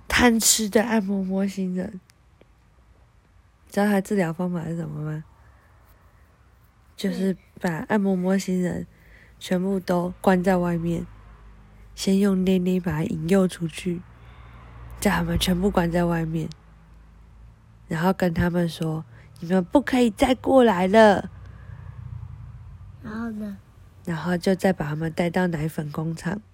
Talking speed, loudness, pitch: 190 characters per minute, -23 LUFS, 175 Hz